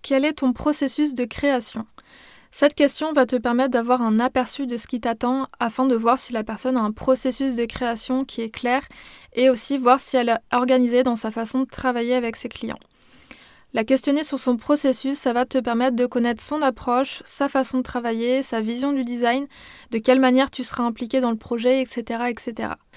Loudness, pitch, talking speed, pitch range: -22 LUFS, 255 Hz, 205 wpm, 240-265 Hz